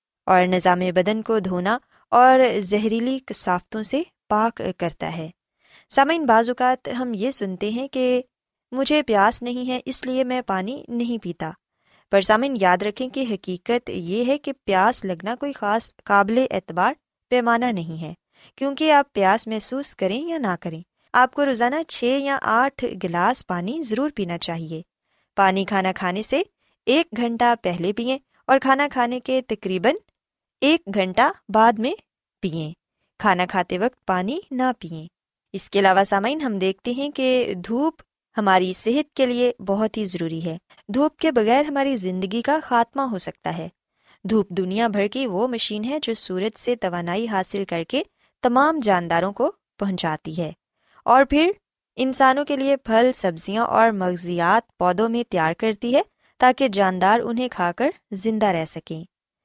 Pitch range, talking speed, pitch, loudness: 190-260 Hz, 160 wpm, 225 Hz, -21 LUFS